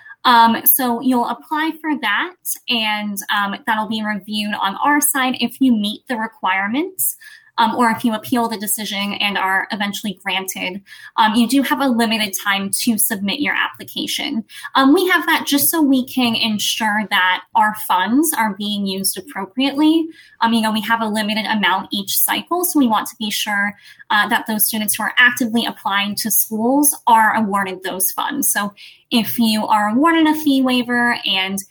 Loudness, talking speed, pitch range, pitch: -17 LUFS, 180 wpm, 205-270 Hz, 225 Hz